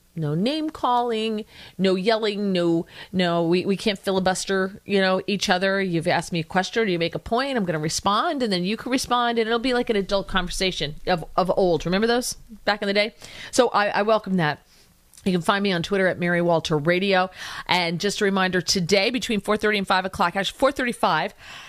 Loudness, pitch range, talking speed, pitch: -22 LUFS, 180-215 Hz, 215 wpm, 195 Hz